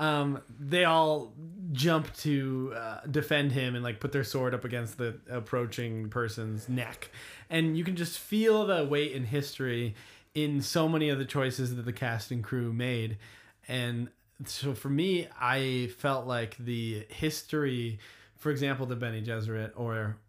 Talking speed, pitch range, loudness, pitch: 165 wpm, 120-150 Hz, -31 LUFS, 130 Hz